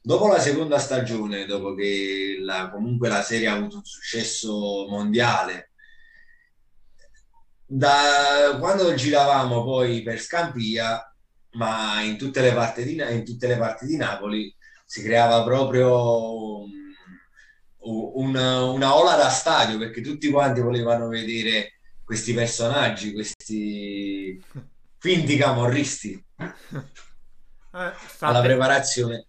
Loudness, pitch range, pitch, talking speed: -22 LUFS, 110-140 Hz, 115 Hz, 110 wpm